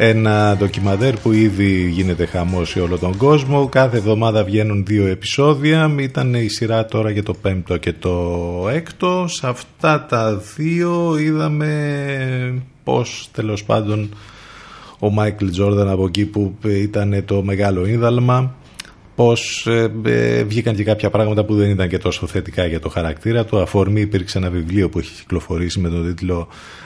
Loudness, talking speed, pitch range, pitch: -18 LUFS, 155 wpm, 95-120 Hz, 105 Hz